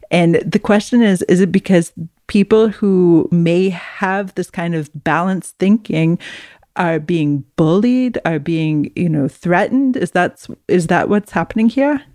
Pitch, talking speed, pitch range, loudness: 180 Hz, 155 wpm, 165-205 Hz, -15 LUFS